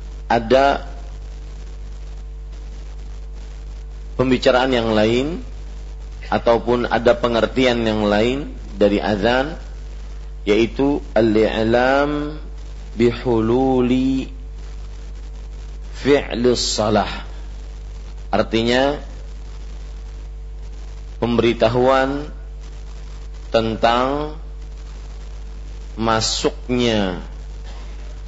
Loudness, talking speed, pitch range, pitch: -18 LUFS, 40 wpm, 75-120 Hz, 105 Hz